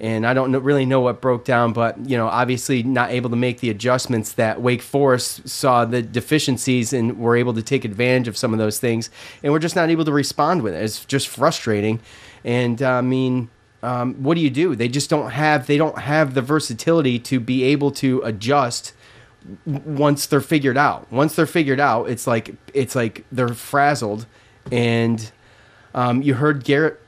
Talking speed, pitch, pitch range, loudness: 200 wpm, 125 Hz, 115-140 Hz, -19 LUFS